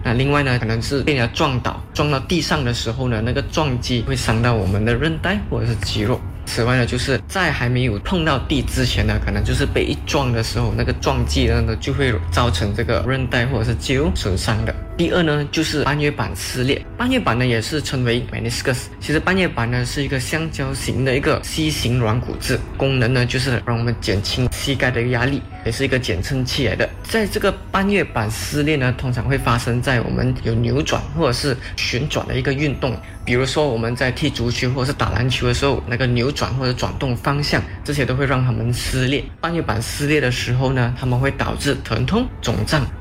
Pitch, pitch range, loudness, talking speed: 125 Hz, 115-140 Hz, -19 LUFS, 335 characters per minute